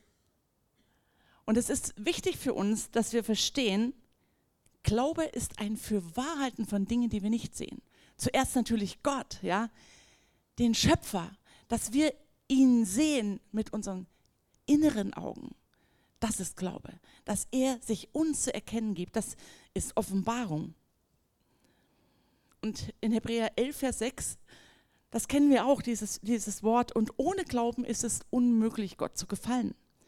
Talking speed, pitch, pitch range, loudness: 135 wpm, 230 Hz, 210-255 Hz, -31 LUFS